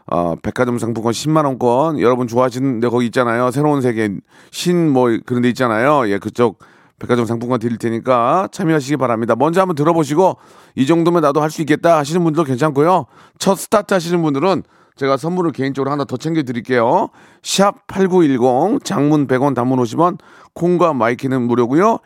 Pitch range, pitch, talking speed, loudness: 120-160 Hz, 135 Hz, 380 characters per minute, -16 LUFS